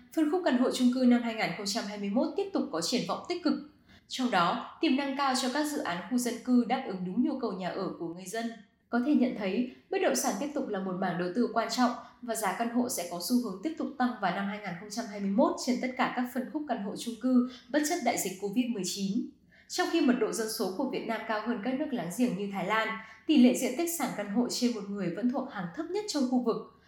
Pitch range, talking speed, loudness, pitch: 210-265 Hz, 265 wpm, -30 LUFS, 240 Hz